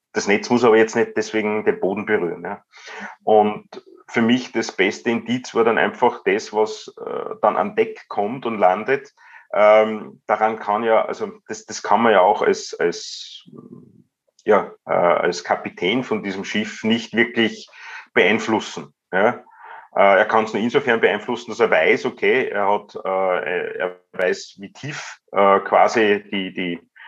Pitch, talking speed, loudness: 115 Hz, 165 wpm, -19 LUFS